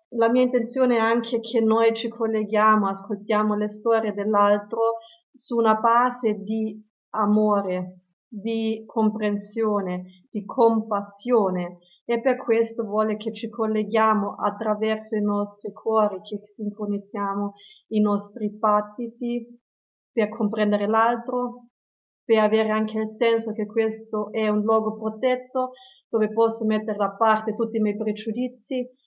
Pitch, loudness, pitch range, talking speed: 220 Hz, -24 LUFS, 210-230 Hz, 125 wpm